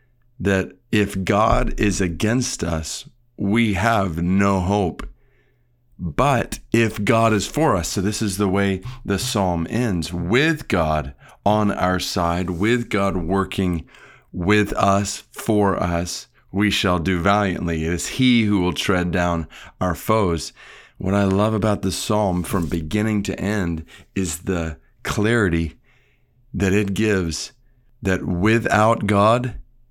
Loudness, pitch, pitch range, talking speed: -21 LUFS, 100 Hz, 90-110 Hz, 135 wpm